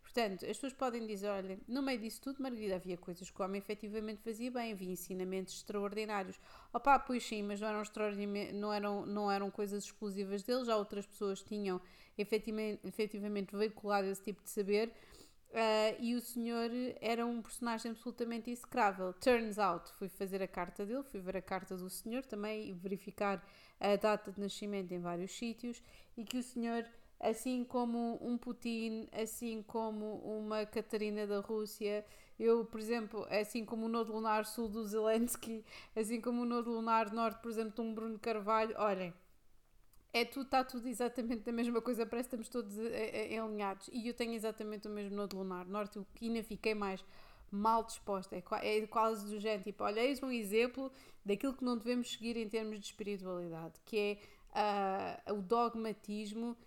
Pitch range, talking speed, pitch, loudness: 205-235 Hz, 180 wpm, 220 Hz, -39 LUFS